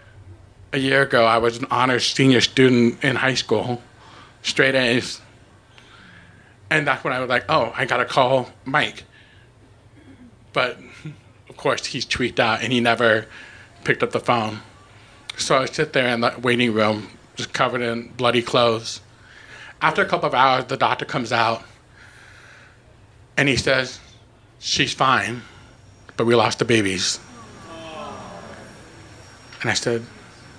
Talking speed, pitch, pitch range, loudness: 145 wpm, 120 Hz, 110-125 Hz, -20 LUFS